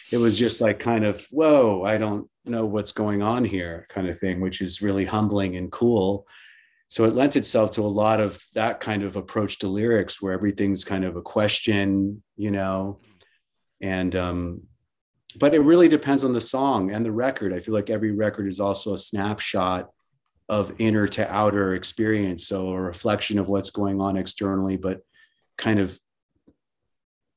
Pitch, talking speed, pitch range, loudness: 105 Hz, 180 wpm, 95-110 Hz, -23 LUFS